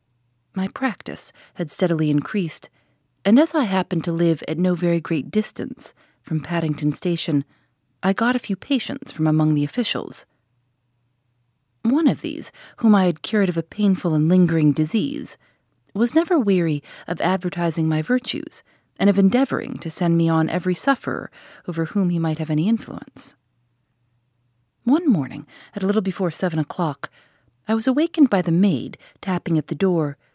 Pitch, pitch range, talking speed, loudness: 170 Hz, 150-205 Hz, 160 wpm, -21 LUFS